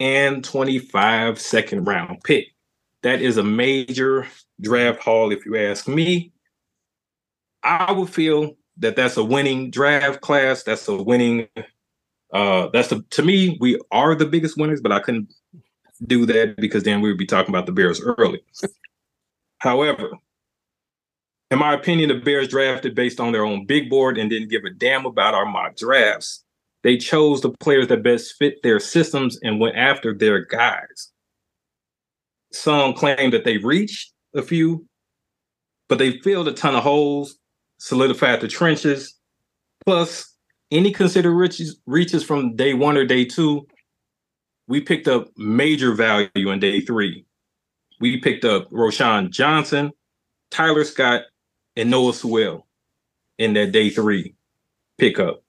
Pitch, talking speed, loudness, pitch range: 135 Hz, 150 wpm, -19 LUFS, 120-155 Hz